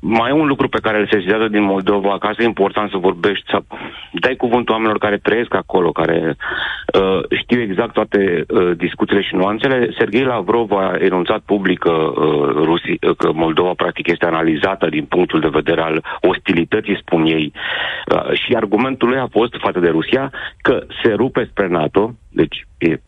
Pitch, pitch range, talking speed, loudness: 100 Hz, 90-110 Hz, 175 wpm, -16 LUFS